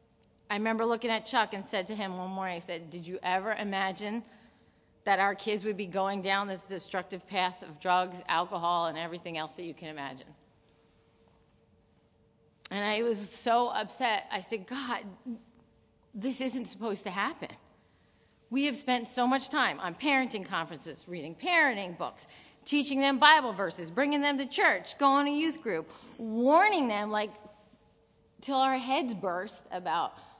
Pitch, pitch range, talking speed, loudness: 210 Hz, 185-250 Hz, 160 wpm, -30 LUFS